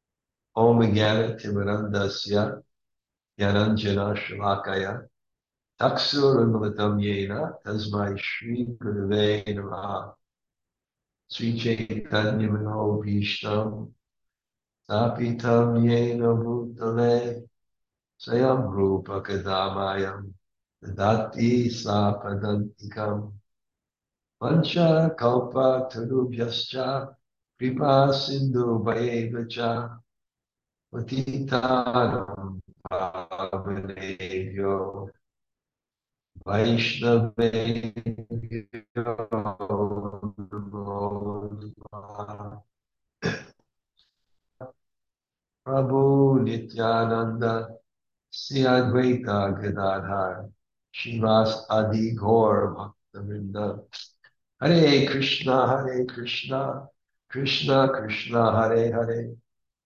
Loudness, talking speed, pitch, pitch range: -25 LUFS, 50 wpm, 110 Hz, 100-120 Hz